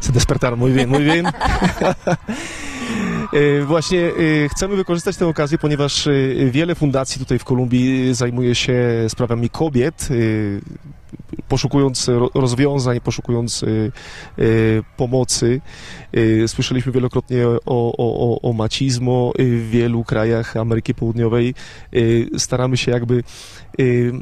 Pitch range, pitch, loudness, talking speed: 120-145 Hz, 125 Hz, -18 LUFS, 95 wpm